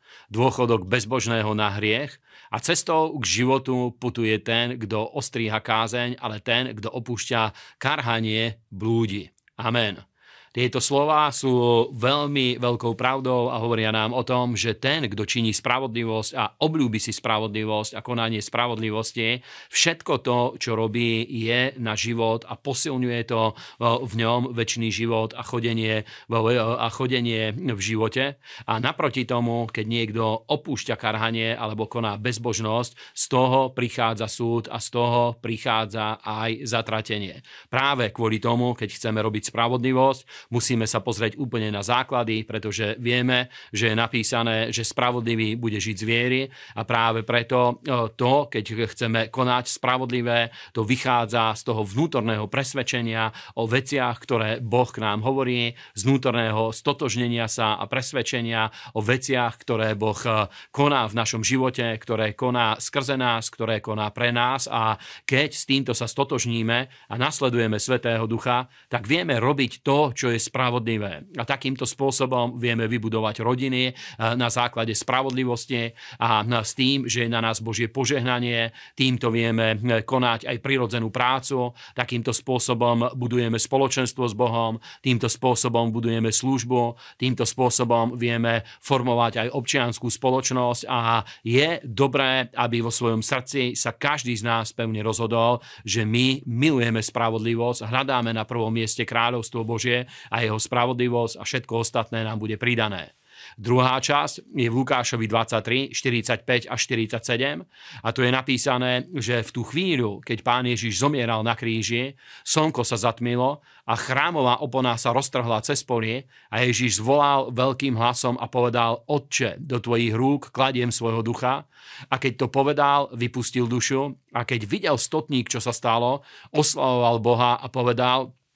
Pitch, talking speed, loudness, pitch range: 120 Hz, 140 wpm, -23 LUFS, 115-130 Hz